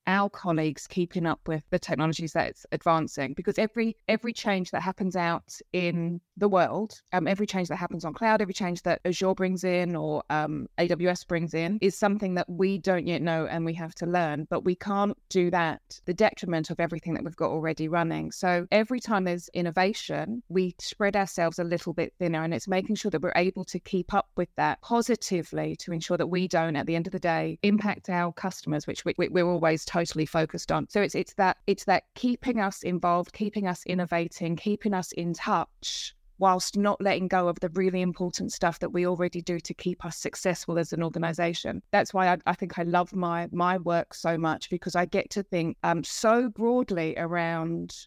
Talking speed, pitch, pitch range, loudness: 205 wpm, 180 Hz, 170-190 Hz, -28 LUFS